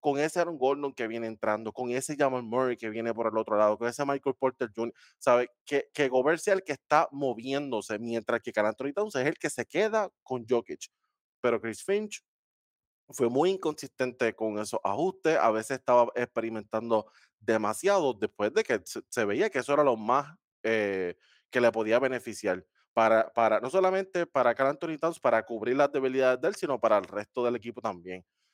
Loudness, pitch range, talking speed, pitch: -29 LUFS, 110-145 Hz, 200 wpm, 125 Hz